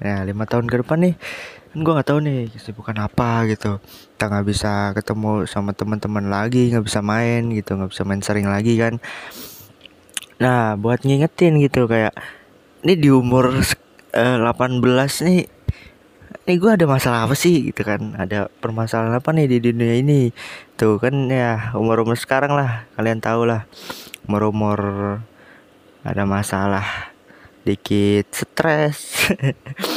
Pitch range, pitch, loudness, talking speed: 105-135 Hz, 115 Hz, -19 LUFS, 140 wpm